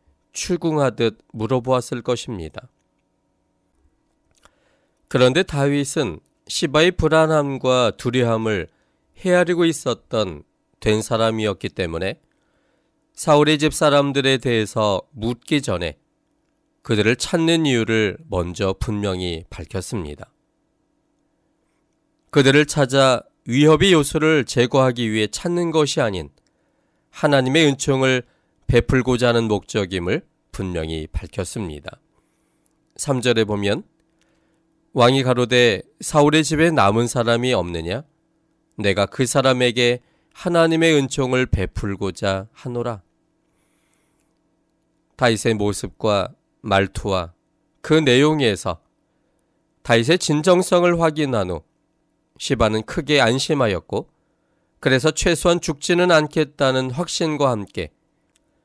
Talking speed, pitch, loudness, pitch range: 230 characters per minute, 130 Hz, -19 LUFS, 110-155 Hz